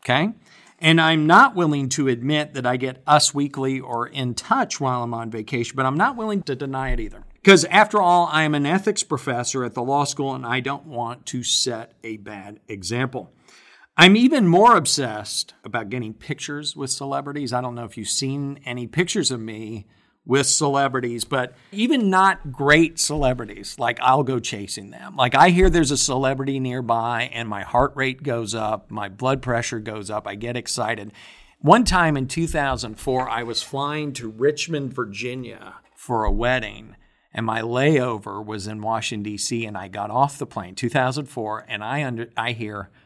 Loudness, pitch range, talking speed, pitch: -21 LUFS, 115-145 Hz, 185 wpm, 130 Hz